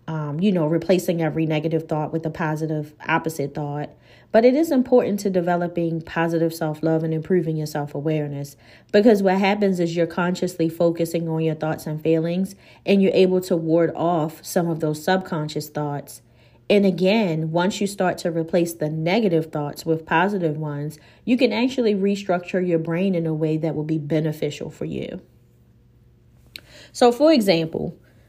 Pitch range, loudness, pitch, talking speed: 155-185 Hz, -22 LUFS, 165 Hz, 170 wpm